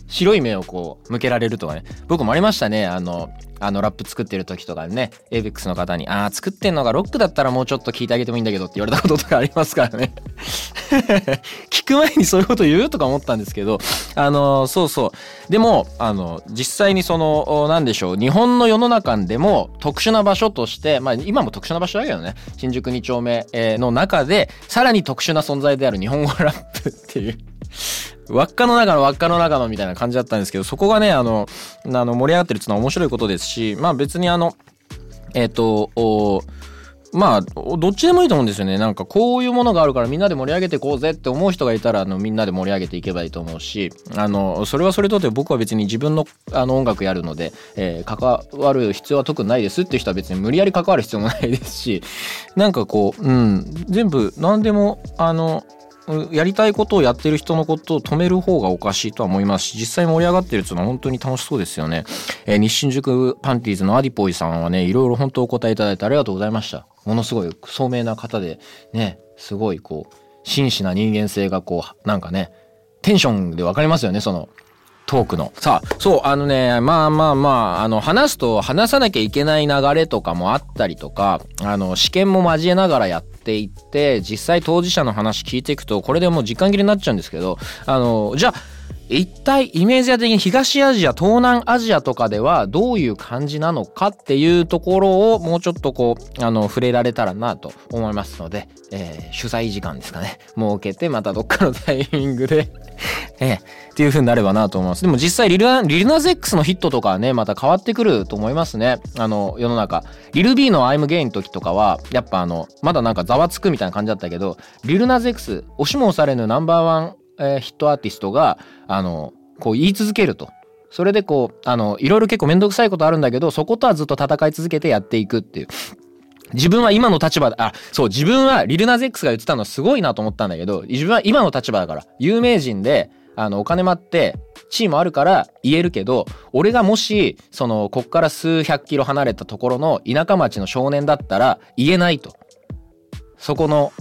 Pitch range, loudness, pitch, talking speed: 105-175 Hz, -18 LUFS, 135 Hz, 435 characters per minute